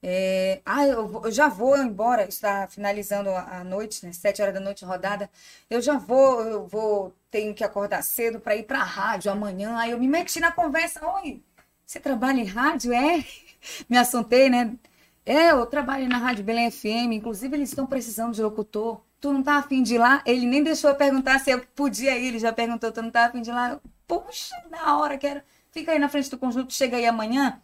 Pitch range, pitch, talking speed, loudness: 215-280 Hz, 245 Hz, 215 wpm, -24 LUFS